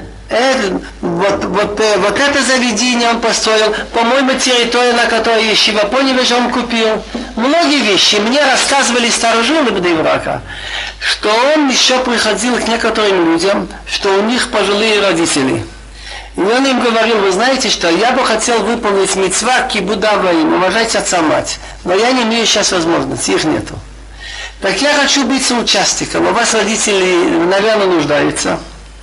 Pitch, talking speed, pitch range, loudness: 225 Hz, 145 wpm, 205-250 Hz, -12 LUFS